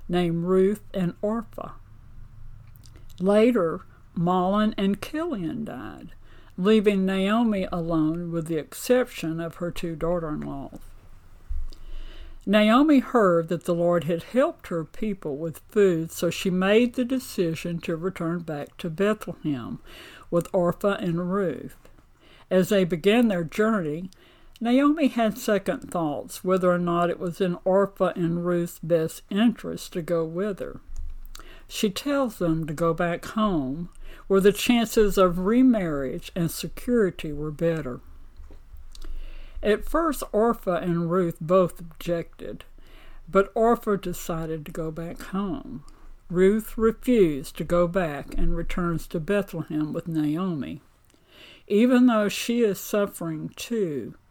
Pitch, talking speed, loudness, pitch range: 180 Hz, 130 wpm, -25 LUFS, 165-210 Hz